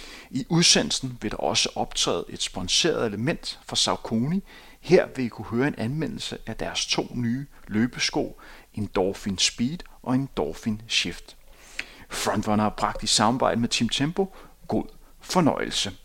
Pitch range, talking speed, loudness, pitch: 105-135 Hz, 145 wpm, -25 LUFS, 120 Hz